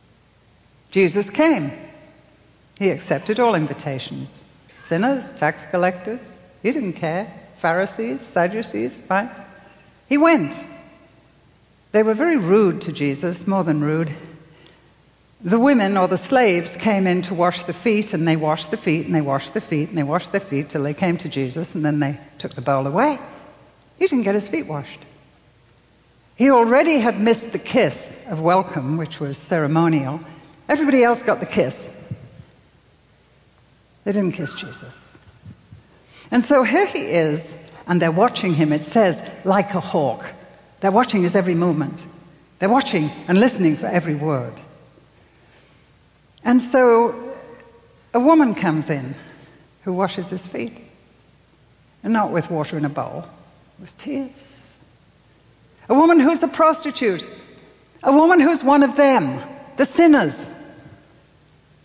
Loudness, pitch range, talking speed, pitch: -19 LUFS, 155-235 Hz, 145 wpm, 180 Hz